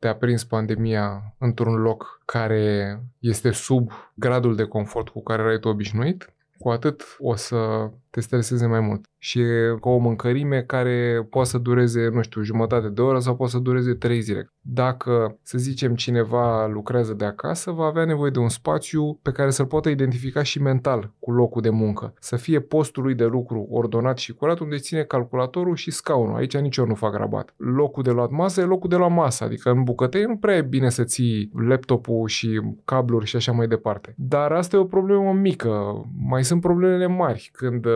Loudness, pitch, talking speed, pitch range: -22 LUFS, 125 Hz, 195 wpm, 115-135 Hz